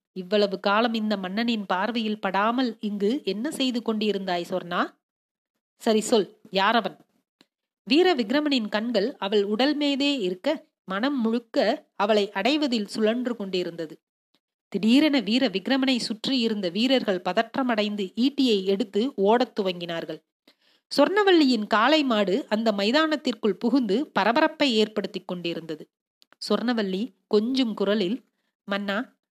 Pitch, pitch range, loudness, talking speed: 220 Hz, 200-260 Hz, -24 LUFS, 100 wpm